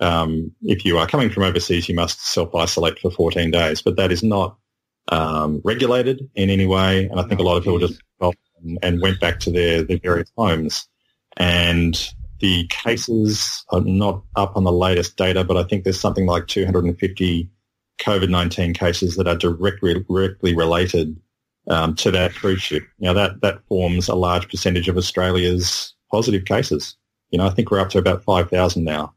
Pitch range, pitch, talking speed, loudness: 85-95 Hz, 90 Hz, 180 wpm, -19 LUFS